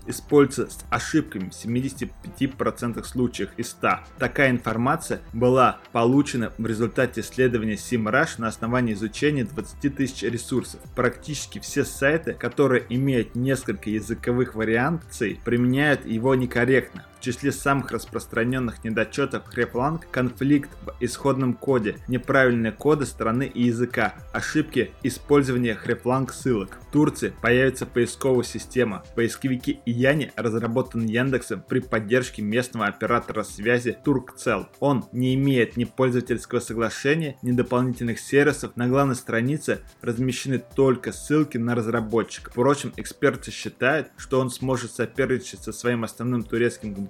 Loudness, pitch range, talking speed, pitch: -24 LUFS, 115-130 Hz, 120 wpm, 120 Hz